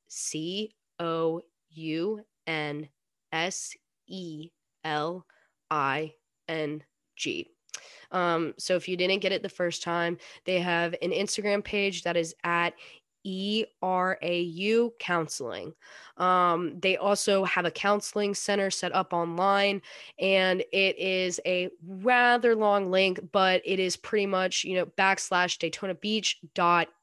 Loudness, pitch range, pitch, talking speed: -27 LUFS, 170-195 Hz, 180 Hz, 135 wpm